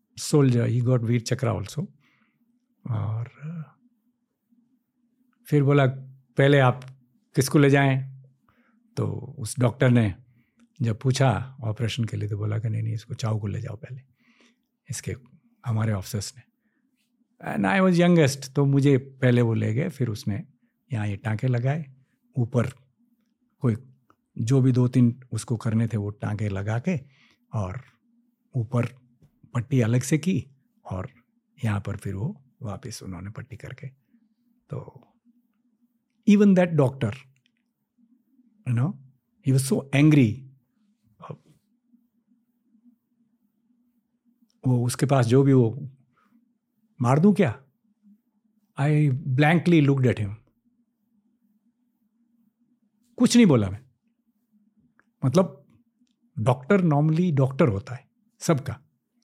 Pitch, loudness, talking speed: 140 Hz, -24 LUFS, 115 wpm